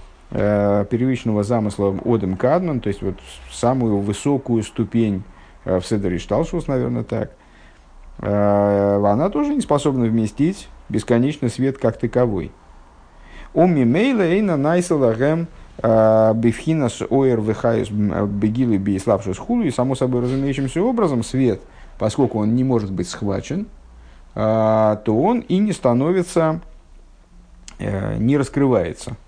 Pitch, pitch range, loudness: 115 Hz, 100-135 Hz, -19 LUFS